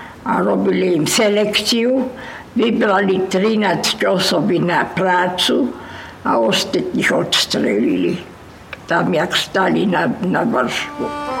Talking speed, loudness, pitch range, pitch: 90 wpm, -16 LUFS, 190-235 Hz, 210 Hz